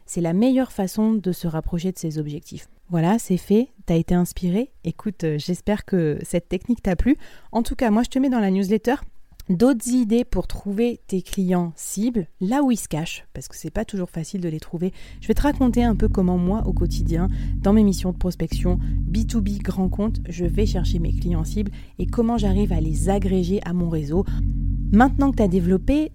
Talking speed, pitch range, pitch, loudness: 215 wpm, 175-230 Hz, 190 Hz, -22 LUFS